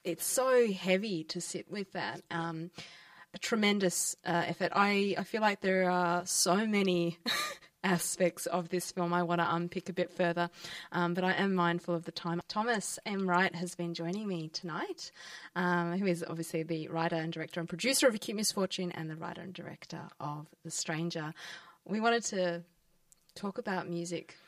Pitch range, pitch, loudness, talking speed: 170-185 Hz, 175 Hz, -33 LUFS, 180 wpm